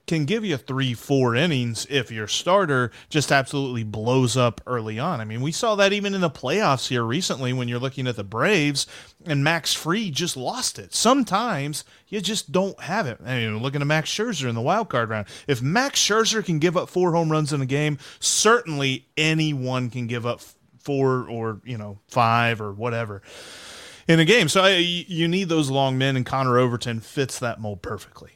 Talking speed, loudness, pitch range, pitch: 205 wpm, -22 LUFS, 120-170 Hz, 140 Hz